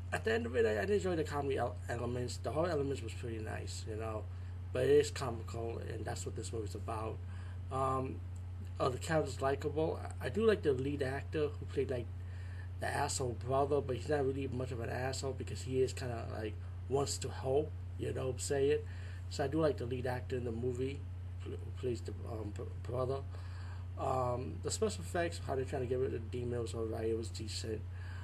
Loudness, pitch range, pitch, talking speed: -38 LUFS, 90-120 Hz, 100 Hz, 220 wpm